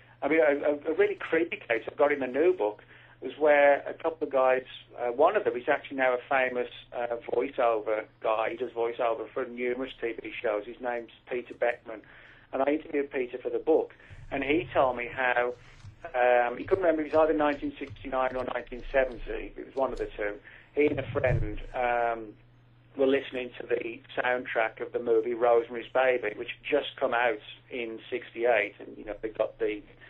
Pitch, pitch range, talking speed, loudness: 130 Hz, 120-145 Hz, 195 wpm, -29 LUFS